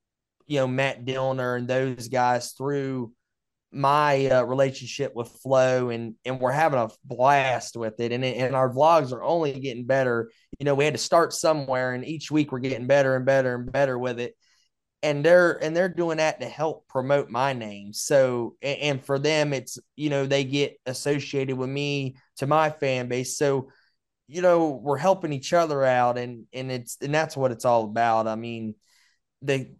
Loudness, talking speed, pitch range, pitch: -24 LUFS, 195 wpm, 125-145 Hz, 130 Hz